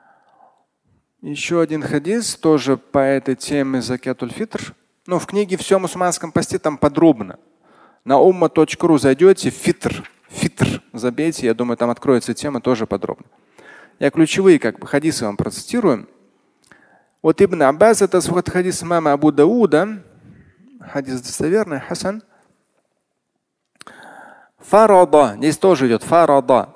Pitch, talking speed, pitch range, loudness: 160 Hz, 120 wpm, 135-190 Hz, -17 LUFS